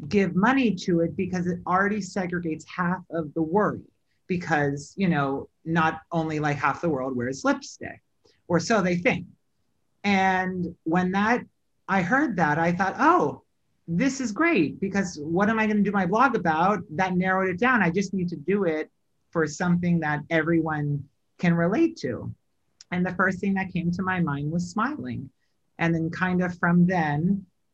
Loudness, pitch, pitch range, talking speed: -25 LUFS, 180 Hz, 165-200 Hz, 180 wpm